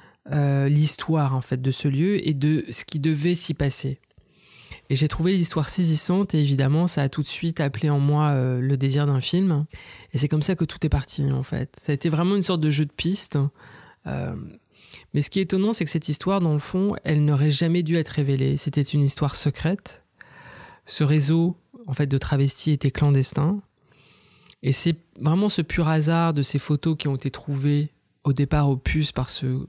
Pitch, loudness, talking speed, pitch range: 150 Hz, -22 LUFS, 210 wpm, 140-165 Hz